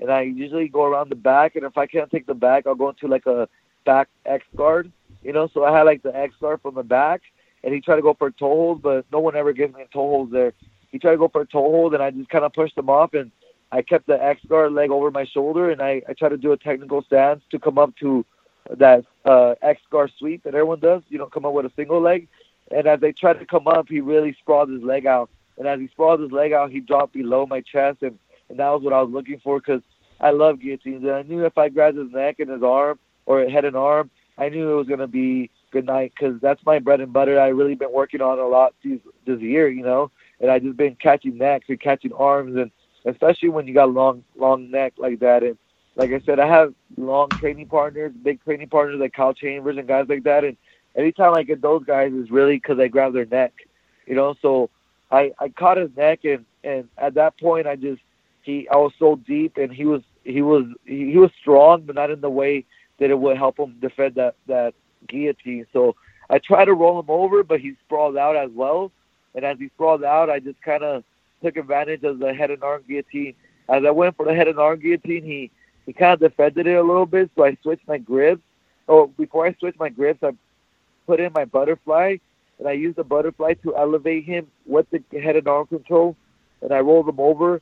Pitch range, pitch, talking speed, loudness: 135-155 Hz, 145 Hz, 250 wpm, -19 LUFS